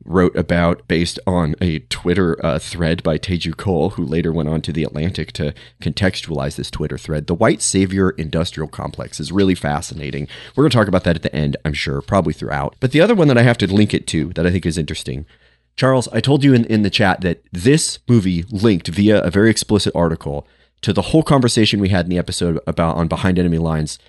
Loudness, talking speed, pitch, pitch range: -17 LUFS, 225 wpm, 85 Hz, 80-105 Hz